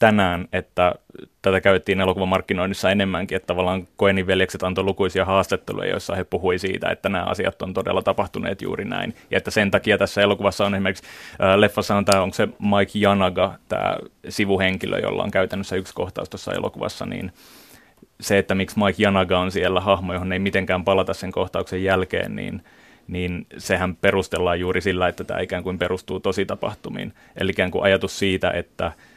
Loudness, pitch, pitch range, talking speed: -22 LUFS, 95 Hz, 90-100 Hz, 175 wpm